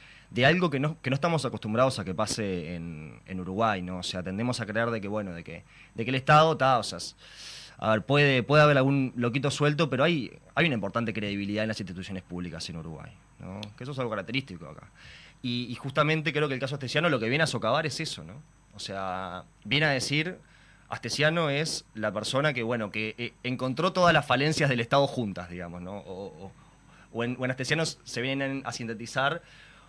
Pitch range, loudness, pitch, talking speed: 105-145 Hz, -27 LUFS, 125 Hz, 220 wpm